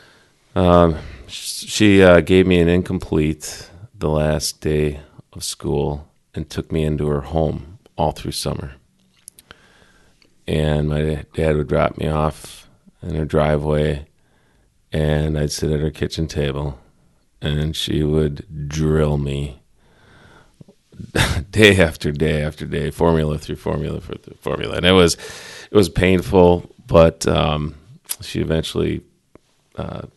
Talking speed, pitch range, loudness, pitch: 125 wpm, 75-80 Hz, -18 LUFS, 75 Hz